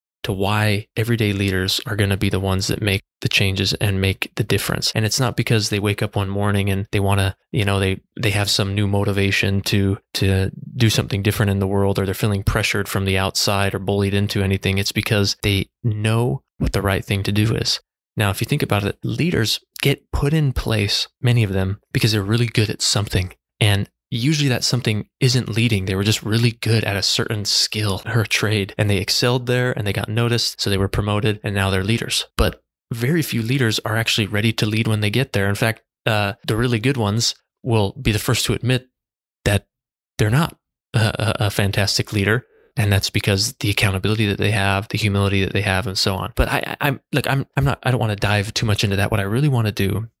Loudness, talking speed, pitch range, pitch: -20 LUFS, 235 wpm, 100-115 Hz, 105 Hz